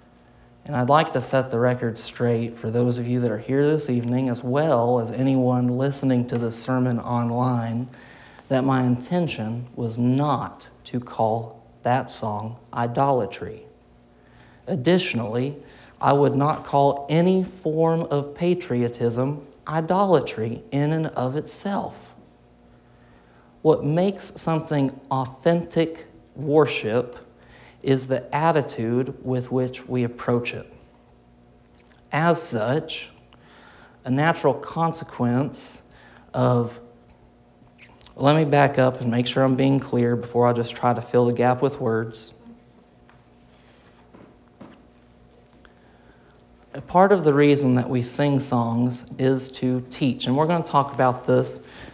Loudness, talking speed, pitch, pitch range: -22 LUFS, 125 wpm, 125 Hz, 115-145 Hz